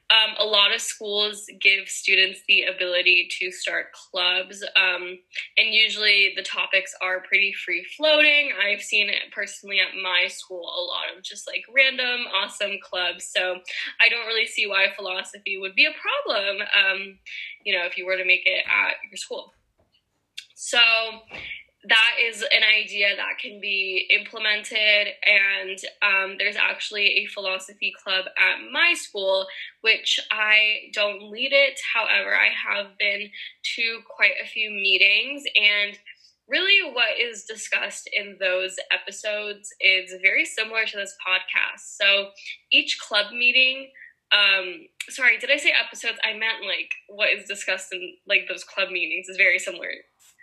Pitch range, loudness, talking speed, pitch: 190-225 Hz, -20 LUFS, 155 wpm, 205 Hz